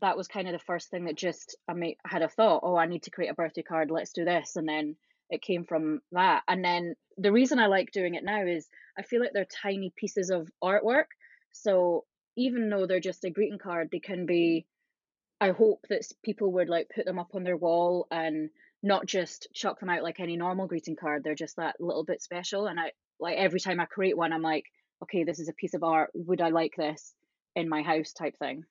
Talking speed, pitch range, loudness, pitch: 240 wpm, 165-195 Hz, -30 LUFS, 175 Hz